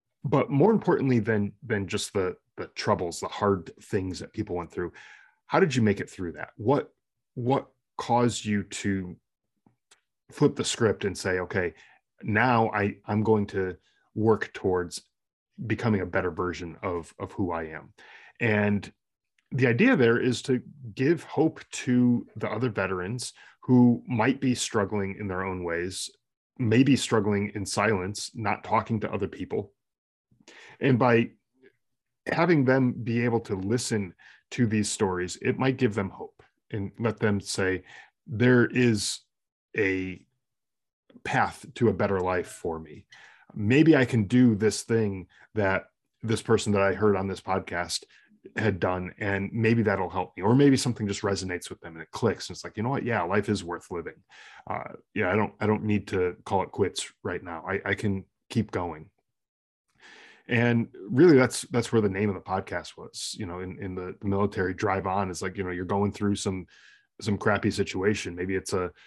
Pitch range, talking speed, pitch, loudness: 95-120 Hz, 175 wpm, 105 Hz, -27 LUFS